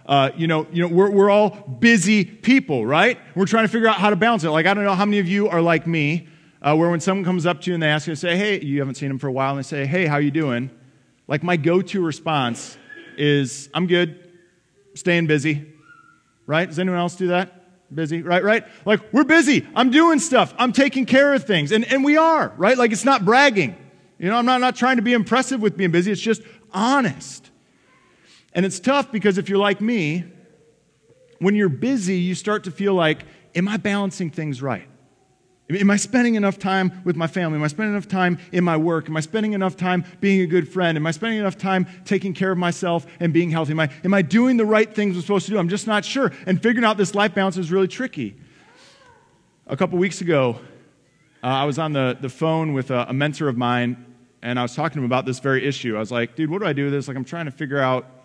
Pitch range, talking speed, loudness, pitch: 155-210 Hz, 245 wpm, -20 LUFS, 180 Hz